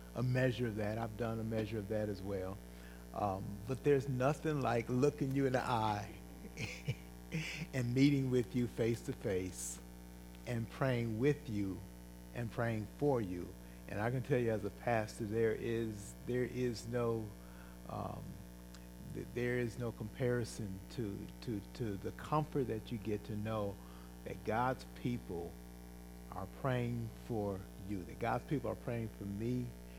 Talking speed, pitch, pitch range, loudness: 160 wpm, 110 Hz, 85-125 Hz, -39 LUFS